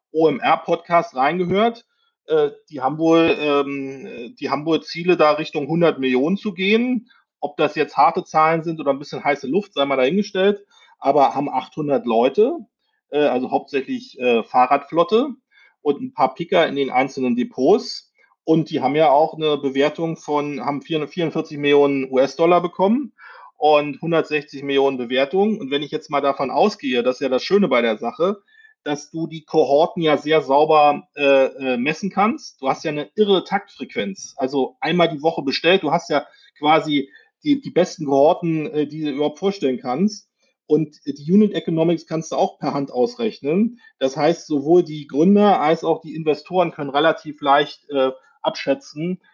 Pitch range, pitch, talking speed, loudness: 140-190 Hz, 155 Hz, 165 wpm, -19 LUFS